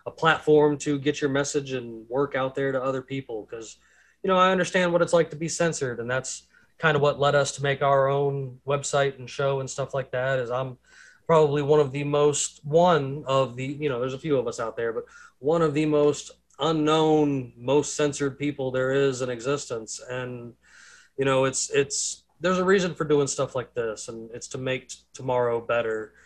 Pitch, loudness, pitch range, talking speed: 140 Hz, -25 LUFS, 130-150 Hz, 215 wpm